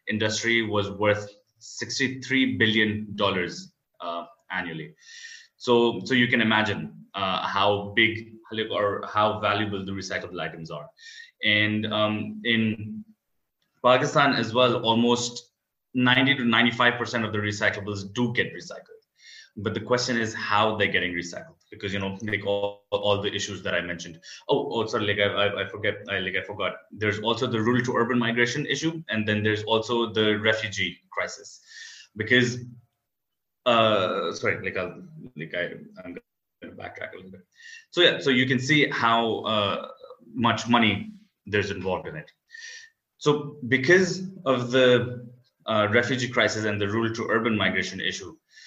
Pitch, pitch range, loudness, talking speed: 115 Hz, 105-125 Hz, -24 LUFS, 155 wpm